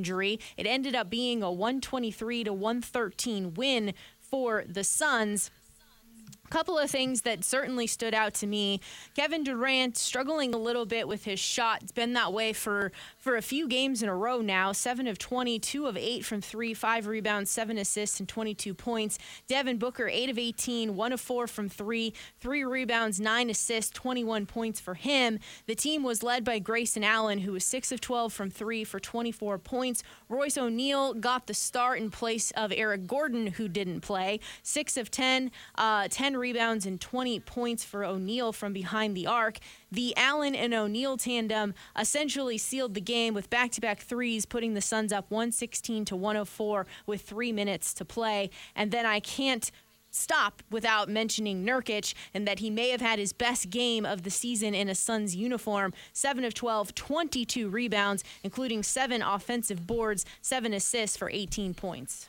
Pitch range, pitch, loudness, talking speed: 205-245 Hz, 225 Hz, -30 LUFS, 175 wpm